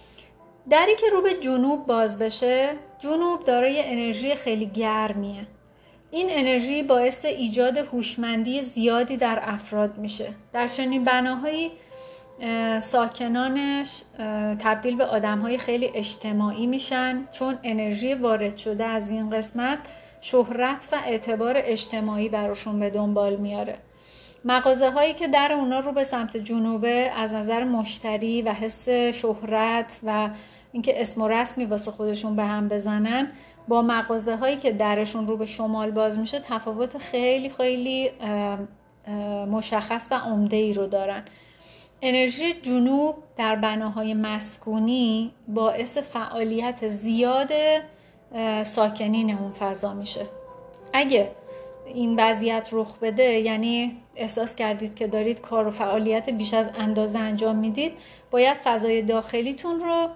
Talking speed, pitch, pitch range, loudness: 125 wpm, 230 Hz, 220-260 Hz, -24 LUFS